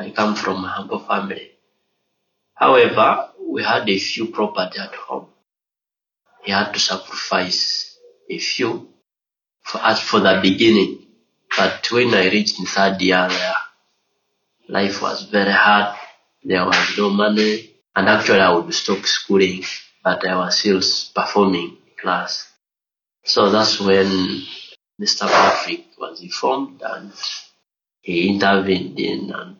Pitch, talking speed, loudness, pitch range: 105 Hz, 130 wpm, -18 LUFS, 95-140 Hz